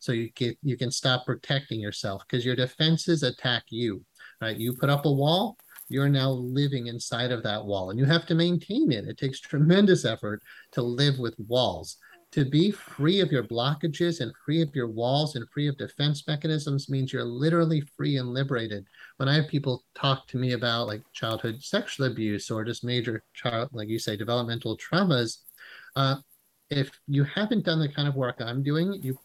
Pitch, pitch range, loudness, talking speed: 130 Hz, 120-150 Hz, -27 LUFS, 195 wpm